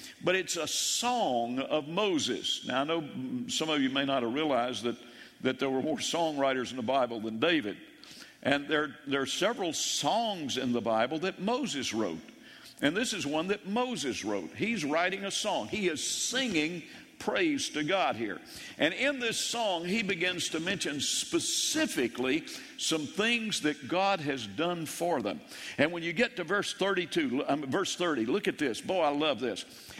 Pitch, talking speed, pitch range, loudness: 170 Hz, 180 wpm, 135-225 Hz, -30 LUFS